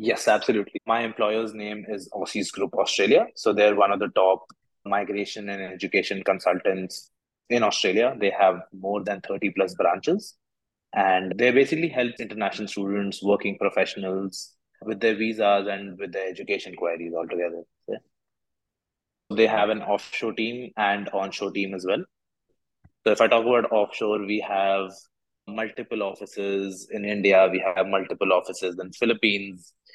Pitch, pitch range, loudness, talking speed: 100 Hz, 95-110 Hz, -24 LUFS, 150 wpm